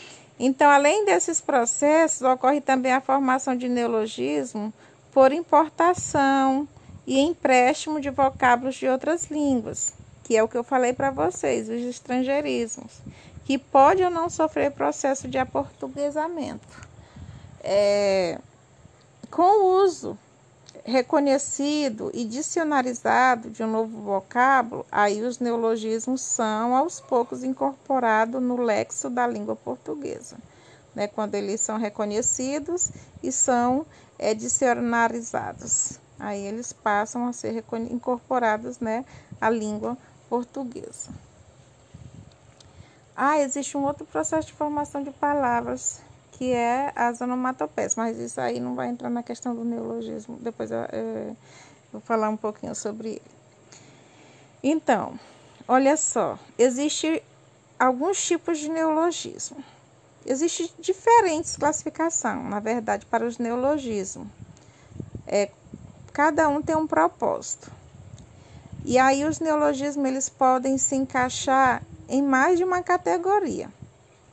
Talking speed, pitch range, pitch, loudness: 120 wpm, 220-290 Hz, 255 Hz, -24 LUFS